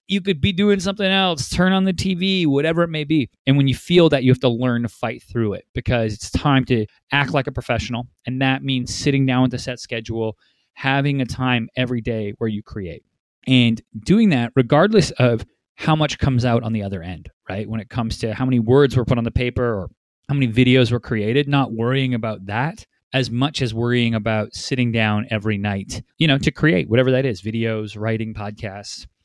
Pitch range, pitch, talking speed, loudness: 110-140 Hz, 125 Hz, 220 wpm, -19 LUFS